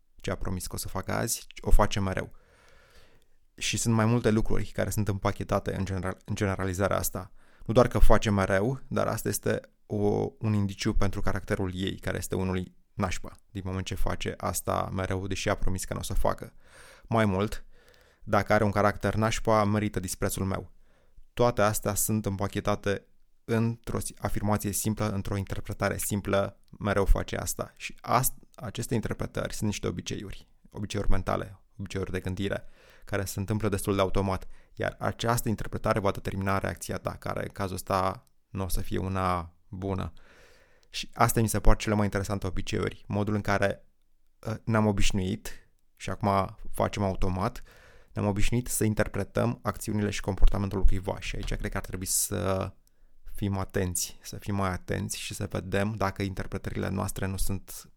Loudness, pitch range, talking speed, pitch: -30 LUFS, 95-105 Hz, 165 wpm, 100 Hz